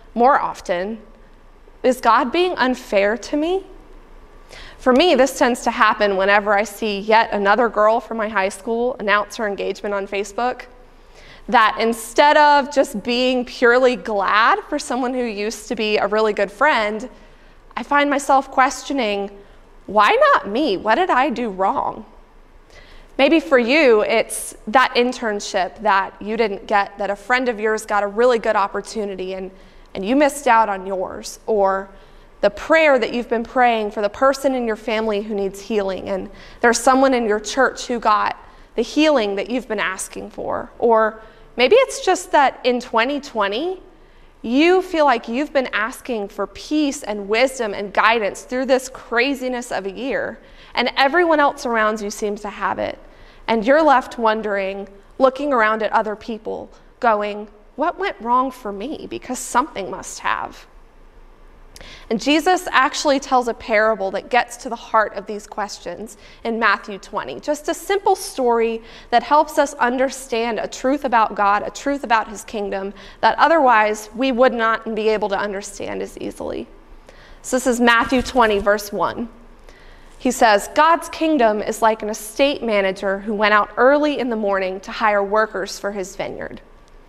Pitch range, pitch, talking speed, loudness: 205-260 Hz, 230 Hz, 165 wpm, -18 LUFS